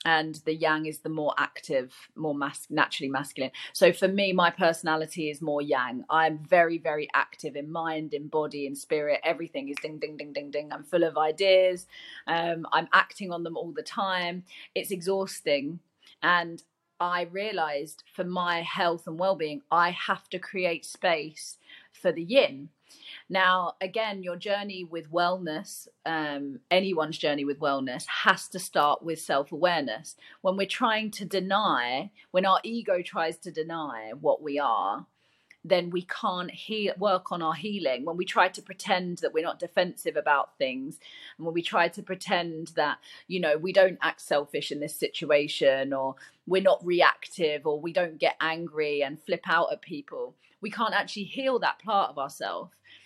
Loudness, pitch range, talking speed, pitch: -28 LUFS, 155-190 Hz, 175 wpm, 170 Hz